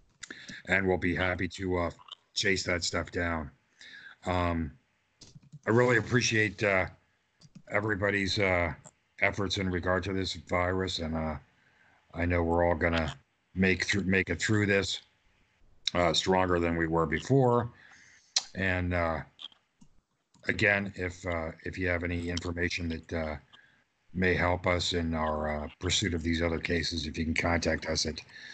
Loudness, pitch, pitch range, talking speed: -29 LUFS, 90 Hz, 85-95 Hz, 150 wpm